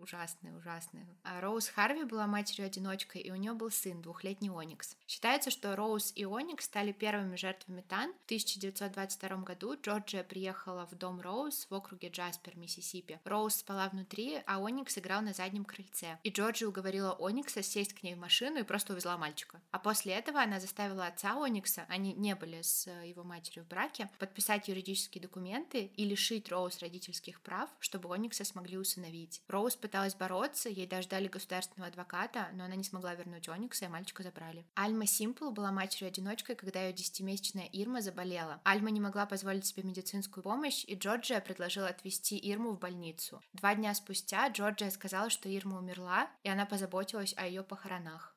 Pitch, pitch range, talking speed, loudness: 195 Hz, 185-210 Hz, 170 wpm, -38 LUFS